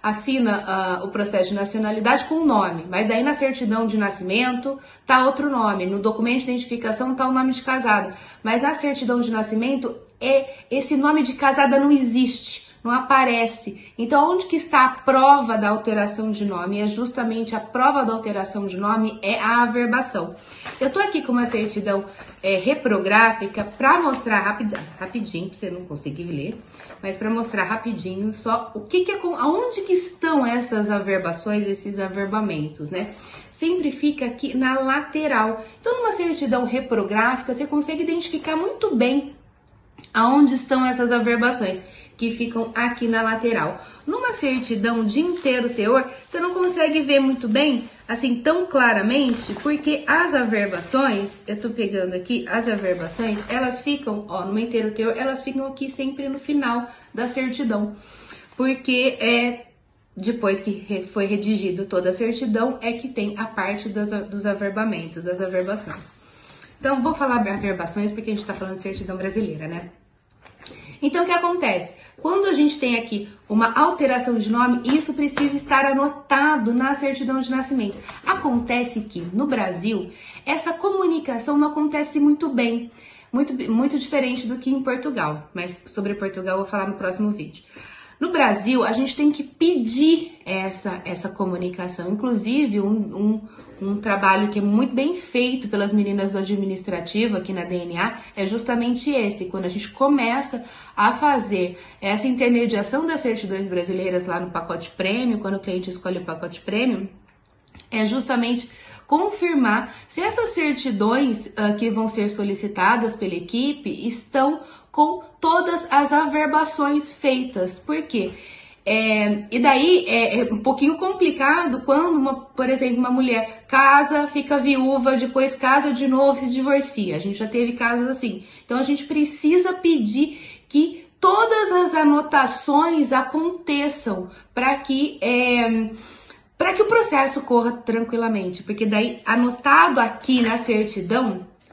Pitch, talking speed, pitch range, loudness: 240 Hz, 155 wpm, 210-275 Hz, -21 LUFS